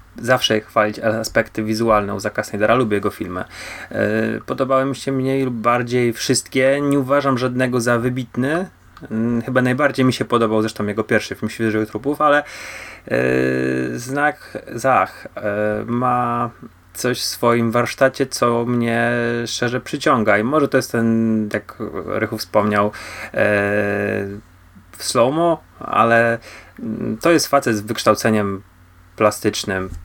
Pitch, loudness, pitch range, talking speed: 115 Hz, -19 LUFS, 105-130 Hz, 130 wpm